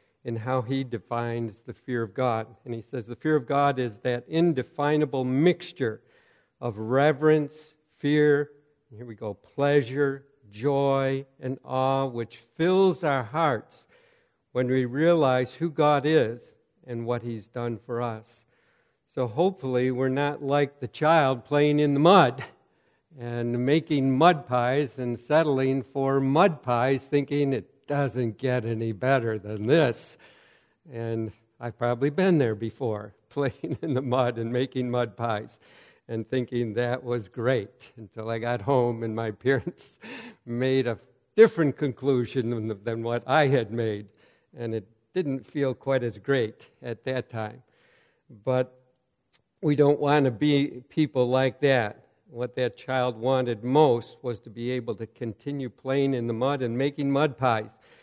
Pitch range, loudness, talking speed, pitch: 120-145 Hz, -26 LUFS, 155 wpm, 130 Hz